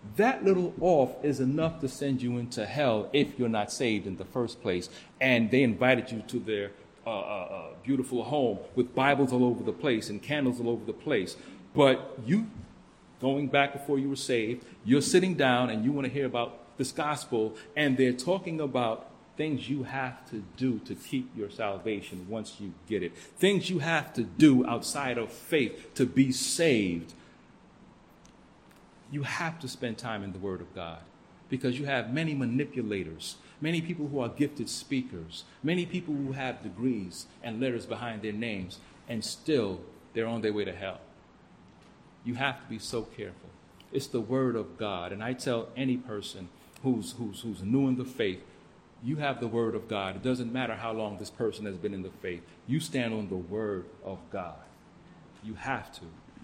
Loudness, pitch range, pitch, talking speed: -30 LUFS, 105-135 Hz, 125 Hz, 190 wpm